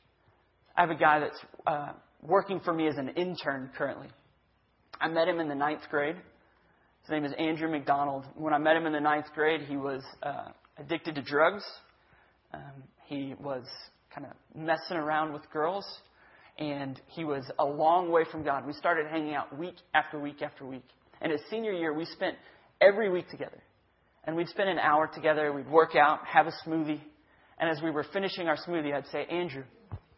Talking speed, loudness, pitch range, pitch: 190 wpm, -30 LUFS, 145-165 Hz, 155 Hz